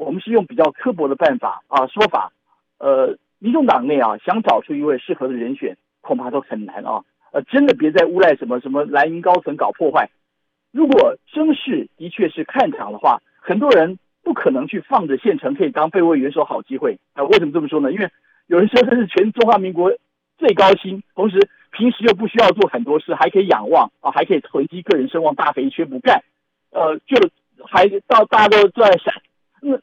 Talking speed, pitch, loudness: 310 characters per minute, 205 Hz, -17 LUFS